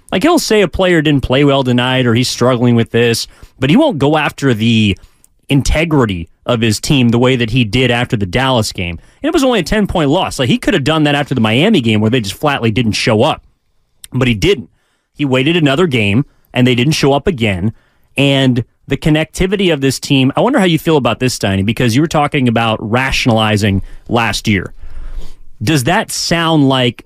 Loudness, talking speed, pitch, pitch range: -13 LUFS, 215 wpm, 130 Hz, 115-150 Hz